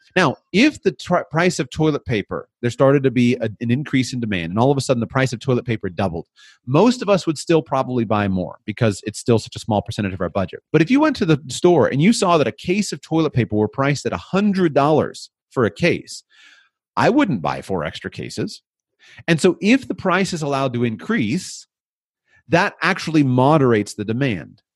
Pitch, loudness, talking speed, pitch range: 135 Hz, -19 LUFS, 215 wpm, 115-170 Hz